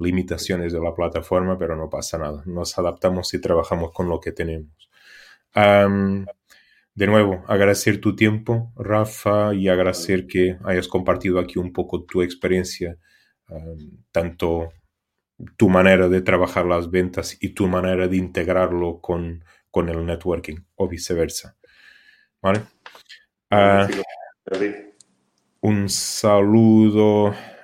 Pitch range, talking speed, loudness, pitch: 85-105 Hz, 120 wpm, -20 LUFS, 90 Hz